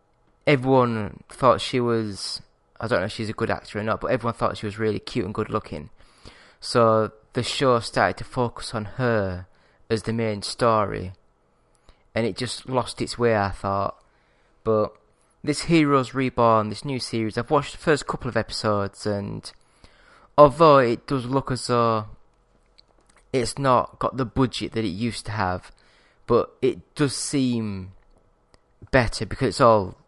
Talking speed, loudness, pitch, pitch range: 165 wpm, -23 LUFS, 115 Hz, 105-125 Hz